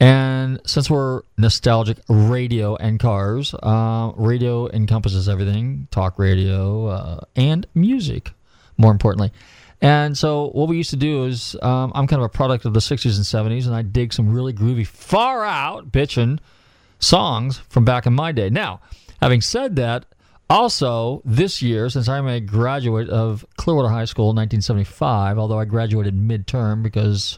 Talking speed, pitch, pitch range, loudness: 160 wpm, 115 Hz, 110-130 Hz, -19 LUFS